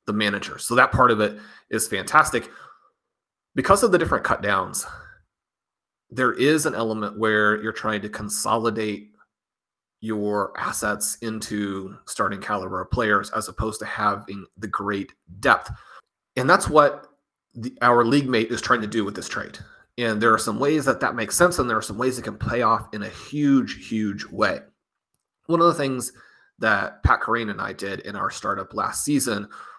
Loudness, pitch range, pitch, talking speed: -22 LUFS, 105-120 Hz, 110 Hz, 180 wpm